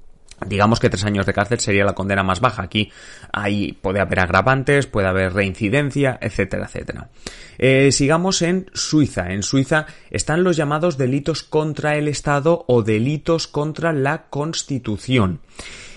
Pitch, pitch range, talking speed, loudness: 130 Hz, 100-150 Hz, 145 wpm, -19 LUFS